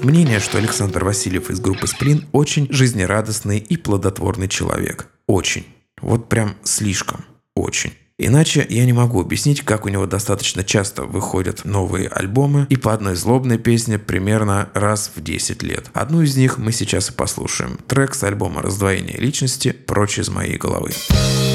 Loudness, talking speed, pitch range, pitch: -18 LUFS, 155 wpm, 95-125 Hz, 105 Hz